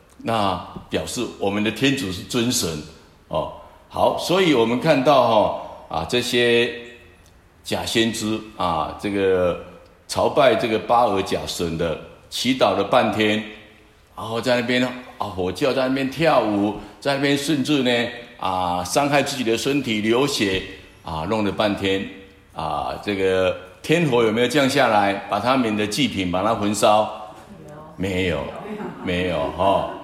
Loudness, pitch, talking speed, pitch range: -21 LUFS, 105 Hz, 215 characters per minute, 95-120 Hz